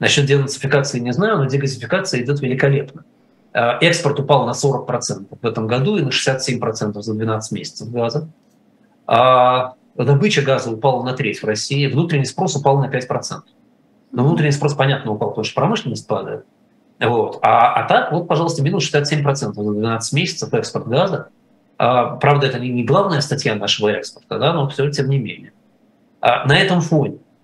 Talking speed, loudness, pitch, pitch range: 165 wpm, -17 LUFS, 135 Hz, 120-145 Hz